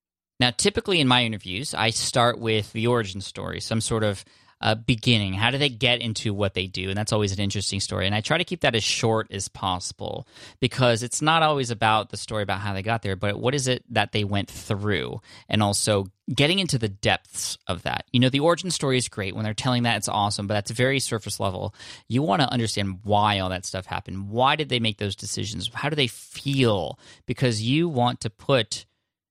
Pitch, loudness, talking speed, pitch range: 110 Hz, -24 LUFS, 225 wpm, 100-125 Hz